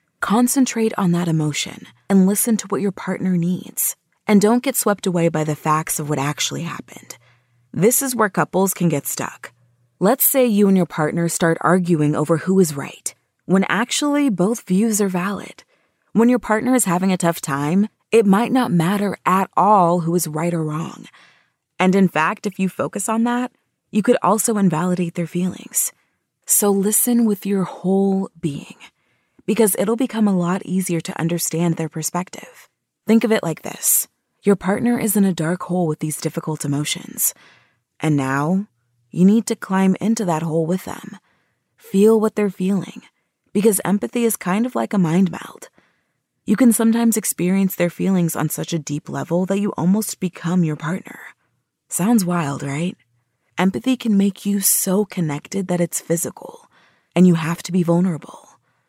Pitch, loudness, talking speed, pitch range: 185 Hz, -19 LUFS, 175 wpm, 170-215 Hz